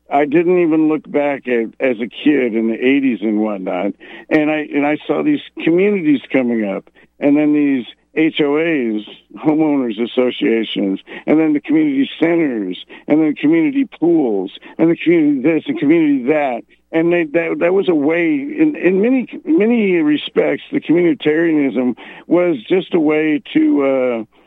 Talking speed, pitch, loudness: 160 wpm, 160 Hz, -16 LUFS